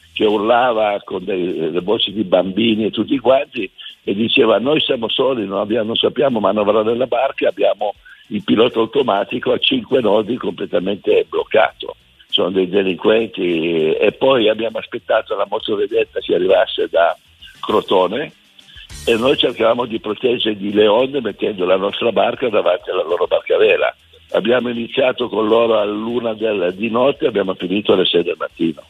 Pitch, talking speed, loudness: 130 Hz, 160 wpm, -17 LUFS